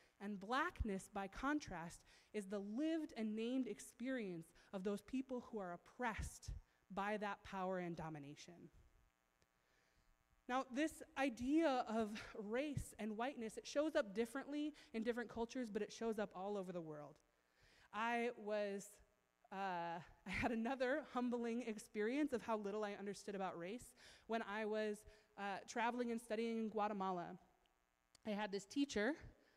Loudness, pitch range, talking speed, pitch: -45 LUFS, 190-245 Hz, 145 wpm, 215 Hz